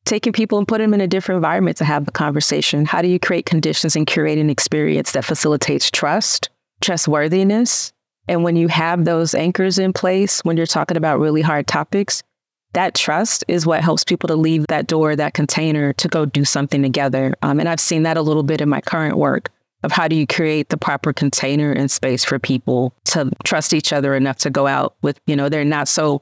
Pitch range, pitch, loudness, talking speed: 145-175 Hz, 155 Hz, -17 LUFS, 220 wpm